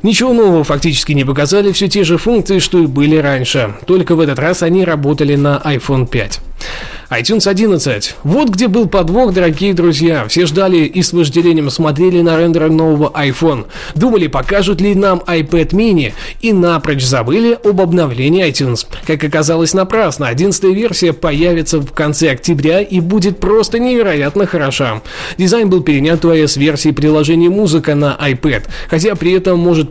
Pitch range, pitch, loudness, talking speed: 150-190 Hz, 165 Hz, -12 LUFS, 160 wpm